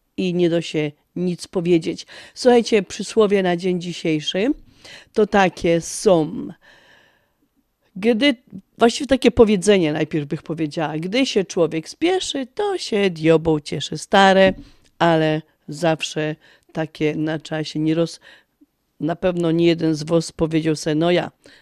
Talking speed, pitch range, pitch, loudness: 130 wpm, 160-205 Hz, 170 Hz, -19 LUFS